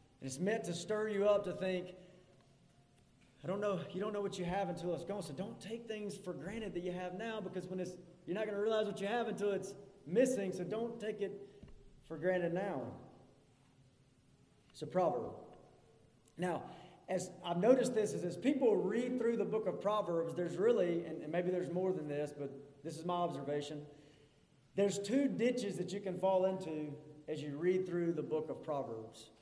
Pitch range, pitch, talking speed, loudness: 150-200 Hz, 180 Hz, 200 wpm, -38 LUFS